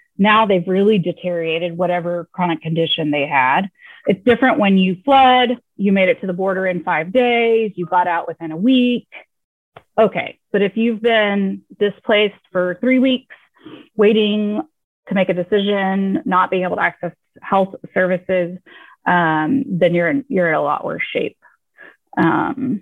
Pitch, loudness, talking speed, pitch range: 195 Hz, -17 LUFS, 160 wpm, 180-230 Hz